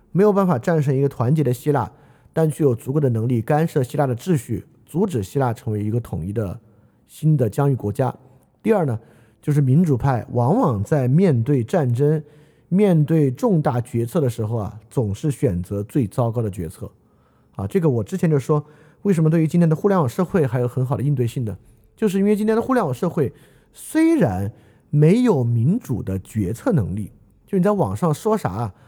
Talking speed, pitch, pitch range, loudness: 295 characters per minute, 140 Hz, 115-160 Hz, -20 LUFS